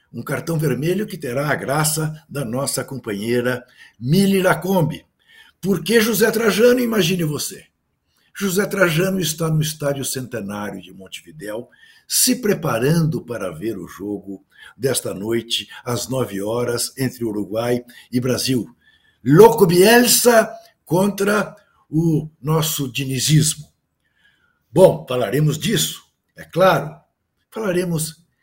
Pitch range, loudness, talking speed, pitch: 125-195 Hz, -19 LUFS, 110 wpm, 155 Hz